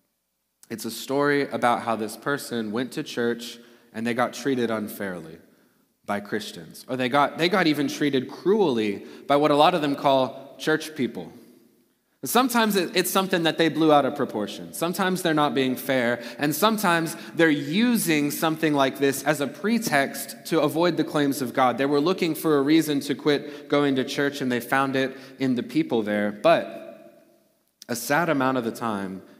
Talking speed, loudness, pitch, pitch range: 185 wpm, -24 LUFS, 140 Hz, 120-160 Hz